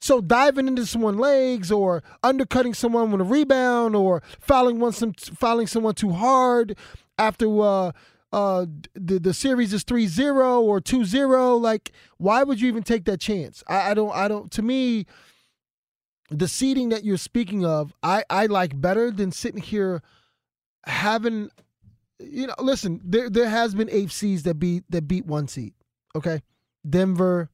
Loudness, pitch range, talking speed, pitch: -22 LUFS, 185-245 Hz, 160 wpm, 215 Hz